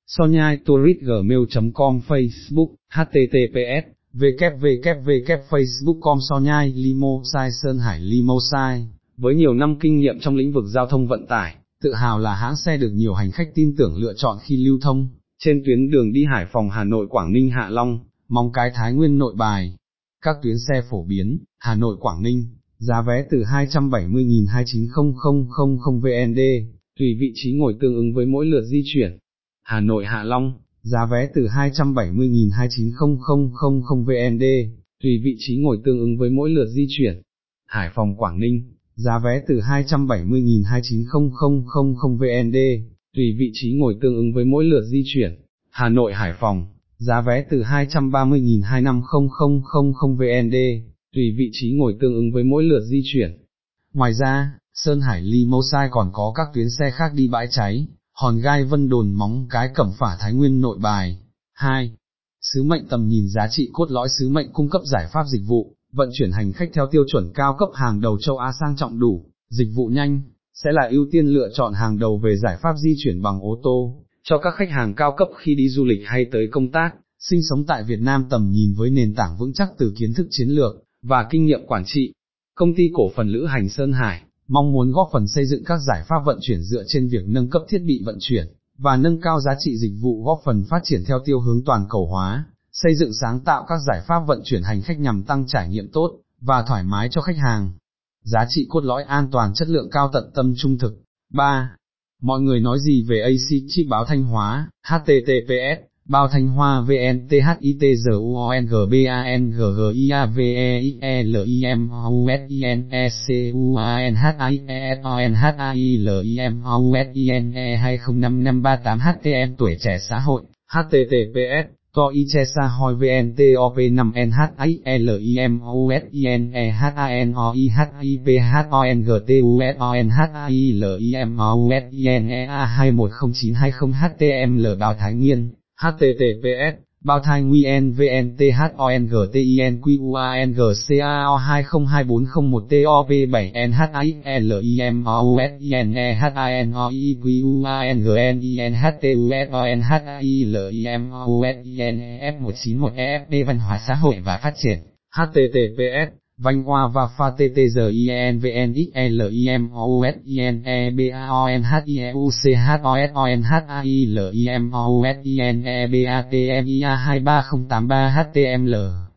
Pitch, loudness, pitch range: 130 Hz, -19 LUFS, 120-140 Hz